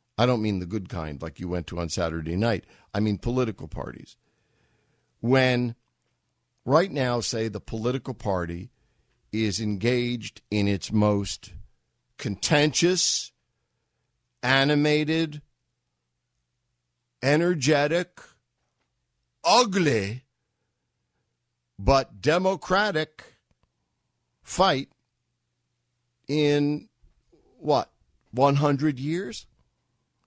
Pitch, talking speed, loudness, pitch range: 120 Hz, 80 wpm, -25 LUFS, 90-145 Hz